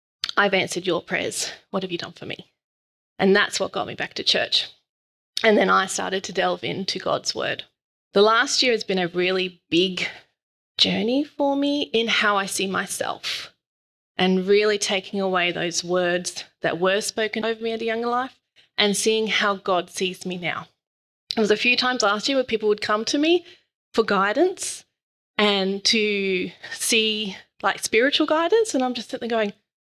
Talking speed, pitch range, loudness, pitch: 185 wpm, 190-235 Hz, -22 LUFS, 205 Hz